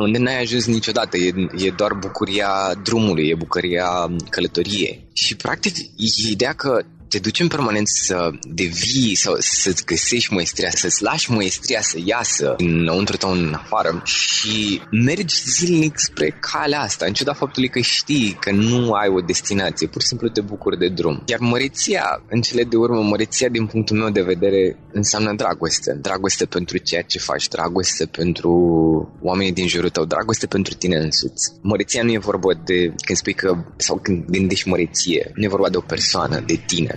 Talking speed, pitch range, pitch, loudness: 175 wpm, 90-115 Hz, 105 Hz, -19 LUFS